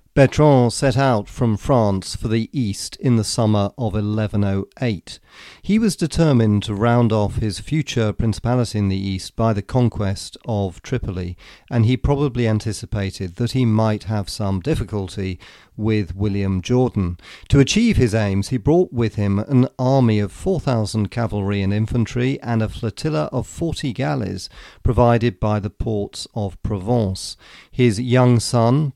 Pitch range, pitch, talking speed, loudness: 100-125 Hz, 110 Hz, 150 wpm, -20 LUFS